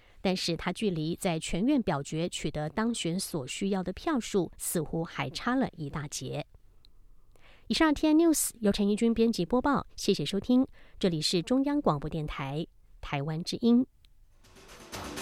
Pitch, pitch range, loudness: 180 Hz, 155-230 Hz, -29 LUFS